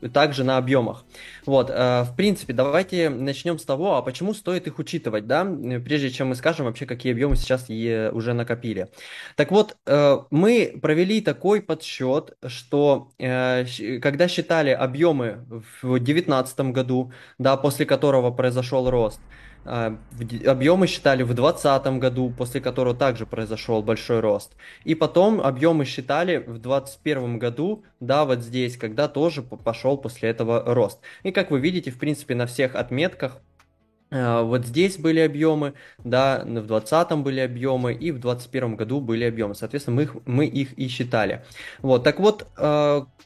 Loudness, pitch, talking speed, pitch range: -23 LUFS, 130 Hz, 145 wpm, 120-150 Hz